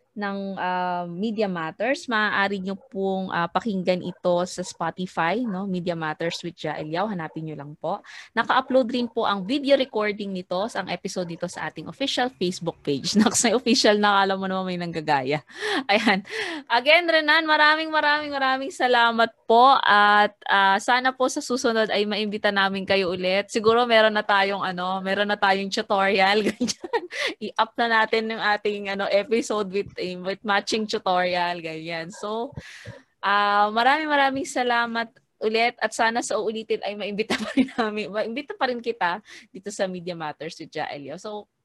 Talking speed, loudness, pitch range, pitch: 160 wpm, -23 LUFS, 185-235 Hz, 205 Hz